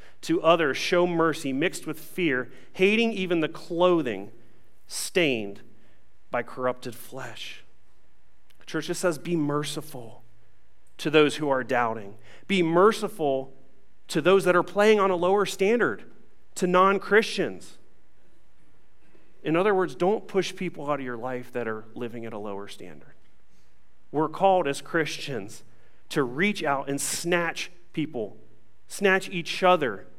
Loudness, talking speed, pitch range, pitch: -25 LUFS, 140 wpm, 120-180 Hz, 150 Hz